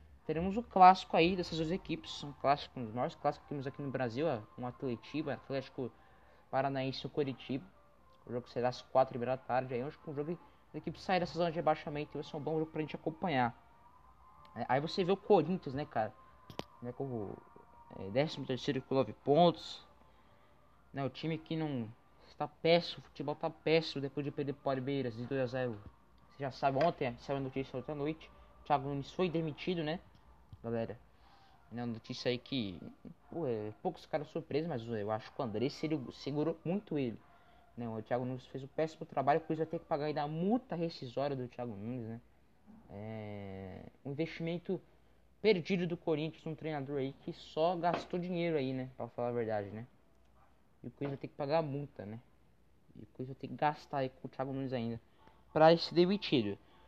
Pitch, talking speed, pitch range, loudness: 140 Hz, 200 wpm, 125-160 Hz, -36 LUFS